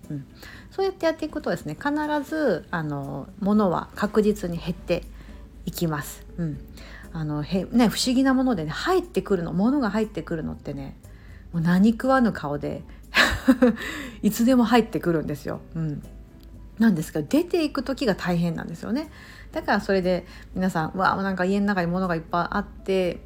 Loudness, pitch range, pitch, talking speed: -24 LUFS, 165-245 Hz, 190 Hz, 345 characters per minute